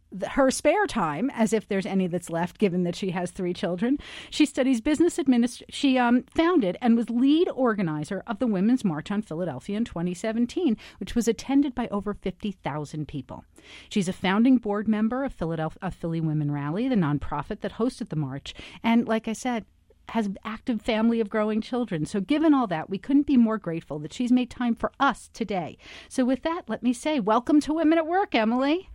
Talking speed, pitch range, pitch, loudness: 200 wpm, 190-255 Hz, 225 Hz, -25 LUFS